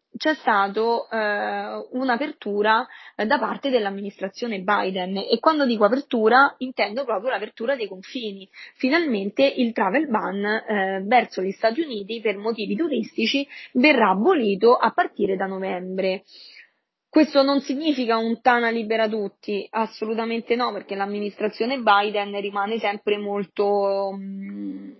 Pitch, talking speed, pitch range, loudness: 220 Hz, 125 wpm, 200-250 Hz, -22 LUFS